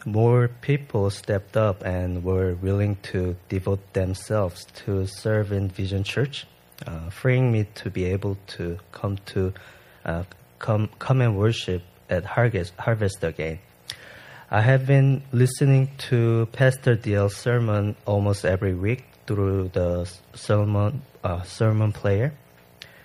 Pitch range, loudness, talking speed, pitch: 95-120 Hz, -24 LUFS, 130 wpm, 100 Hz